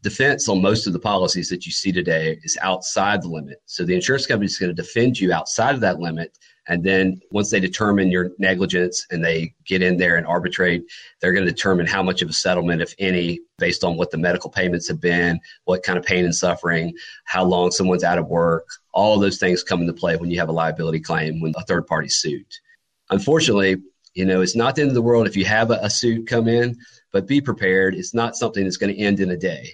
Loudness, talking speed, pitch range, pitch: -20 LUFS, 245 wpm, 85-105 Hz, 95 Hz